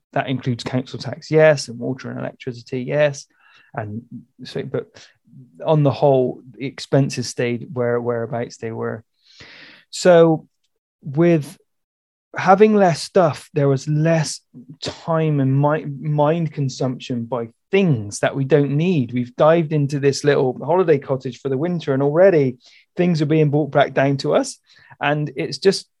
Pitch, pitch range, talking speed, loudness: 140 Hz, 130-160 Hz, 150 wpm, -19 LUFS